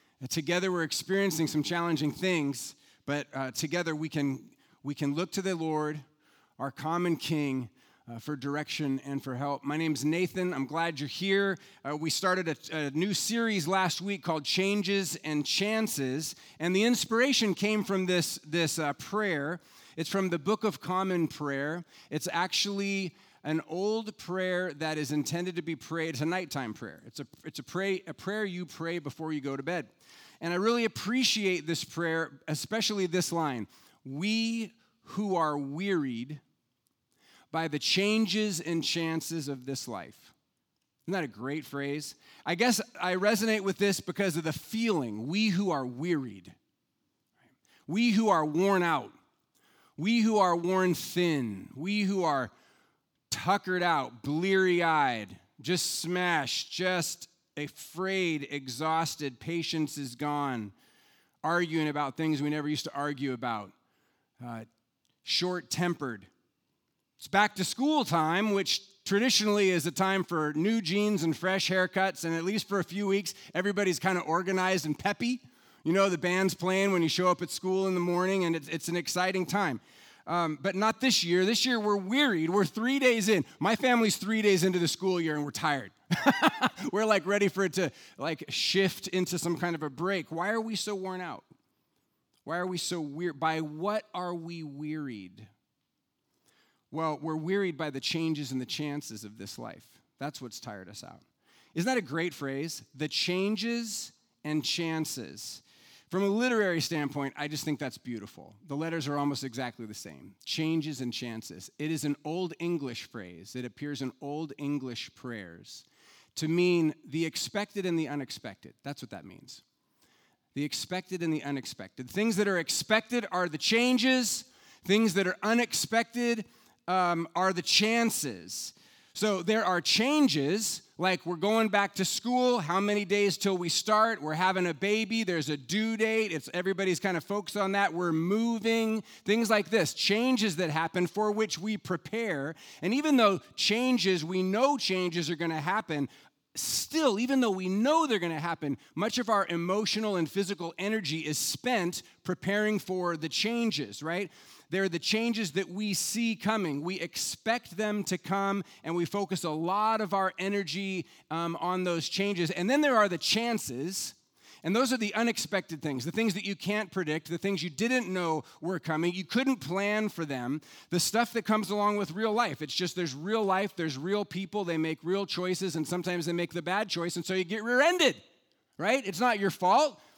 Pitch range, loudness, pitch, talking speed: 155-200 Hz, -30 LUFS, 180 Hz, 175 wpm